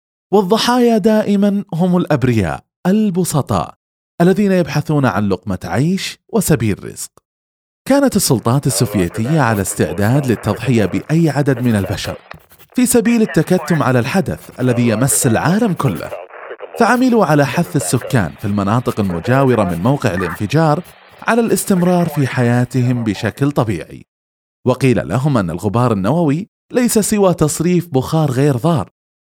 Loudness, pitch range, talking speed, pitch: -15 LUFS, 110-180 Hz, 120 wpm, 140 Hz